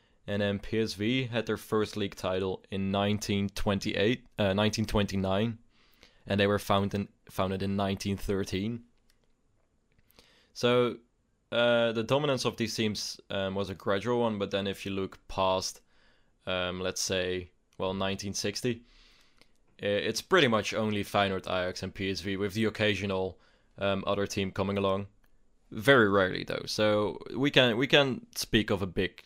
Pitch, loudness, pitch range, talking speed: 100 Hz, -29 LUFS, 95-115 Hz, 145 wpm